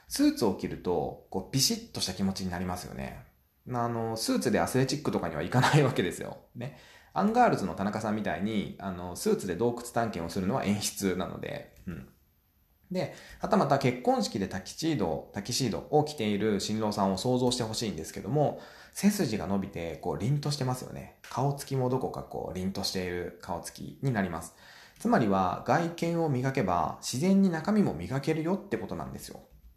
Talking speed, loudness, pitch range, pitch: 405 characters per minute, -30 LUFS, 95-145 Hz, 120 Hz